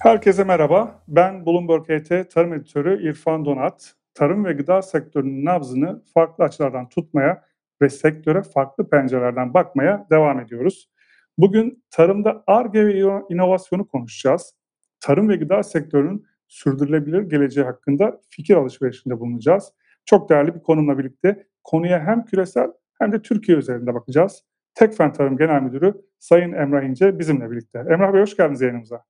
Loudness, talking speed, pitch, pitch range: -19 LUFS, 140 wpm, 165 Hz, 140-190 Hz